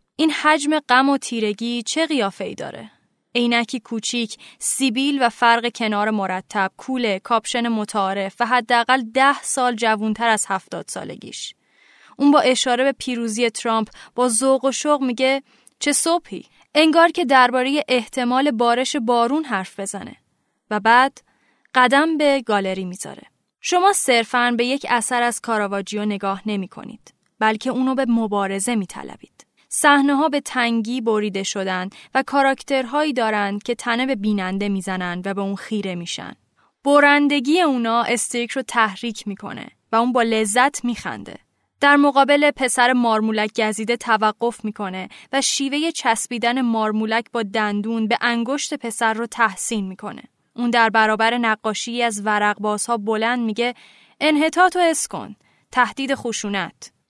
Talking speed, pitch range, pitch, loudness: 140 wpm, 215-265 Hz, 235 Hz, -19 LUFS